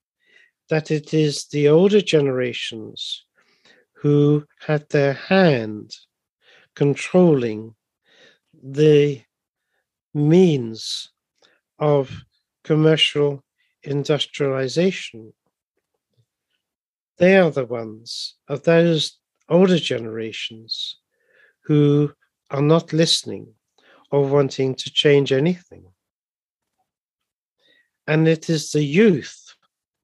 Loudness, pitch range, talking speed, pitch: -19 LUFS, 130-165 Hz, 75 wpm, 145 Hz